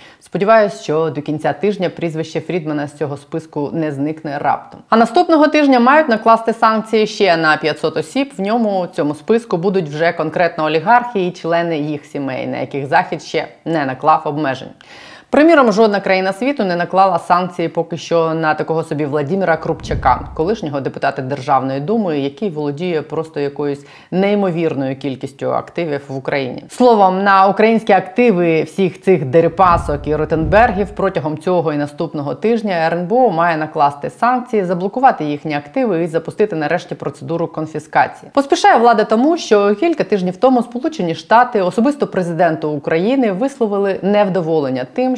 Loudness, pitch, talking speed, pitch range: -15 LUFS, 175 Hz, 145 wpm, 155-215 Hz